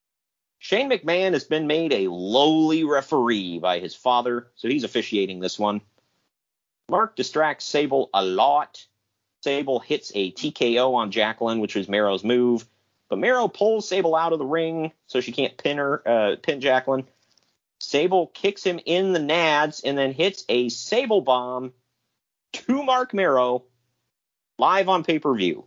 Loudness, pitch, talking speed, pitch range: -22 LUFS, 130 Hz, 150 wpm, 115-160 Hz